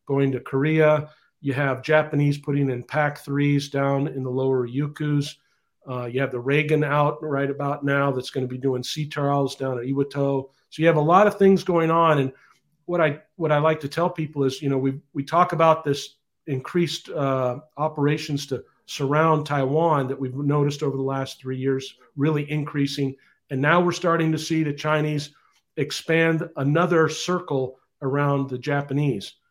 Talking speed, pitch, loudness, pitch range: 185 wpm, 145 Hz, -23 LUFS, 135-155 Hz